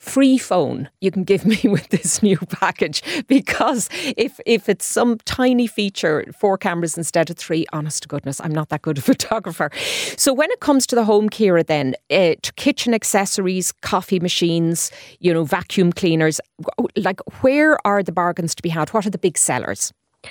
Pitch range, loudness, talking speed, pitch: 165-240 Hz, -19 LUFS, 190 wpm, 195 Hz